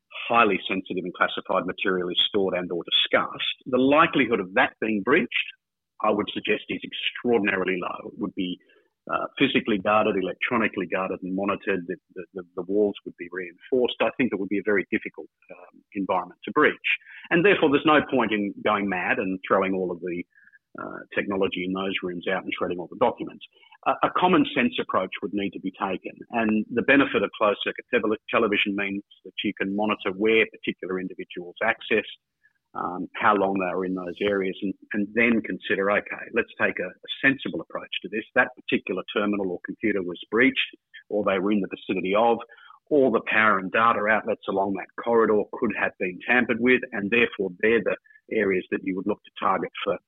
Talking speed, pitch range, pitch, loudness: 195 wpm, 95-110 Hz, 100 Hz, -24 LUFS